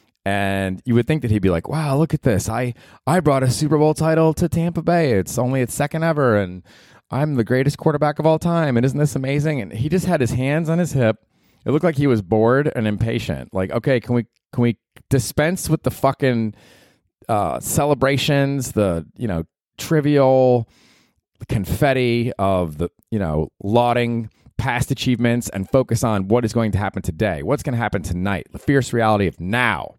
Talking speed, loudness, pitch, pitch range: 200 wpm, -20 LUFS, 125 Hz, 110-145 Hz